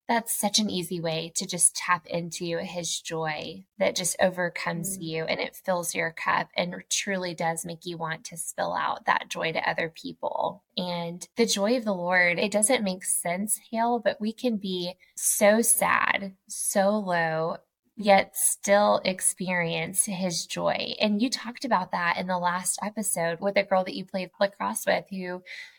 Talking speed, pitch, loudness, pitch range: 175 wpm, 185 Hz, -26 LUFS, 175-210 Hz